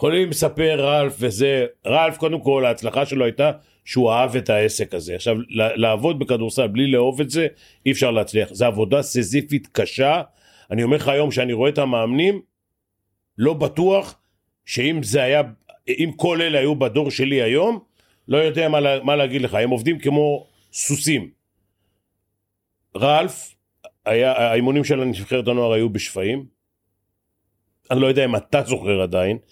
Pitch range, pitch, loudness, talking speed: 110-150 Hz, 130 Hz, -20 LUFS, 150 wpm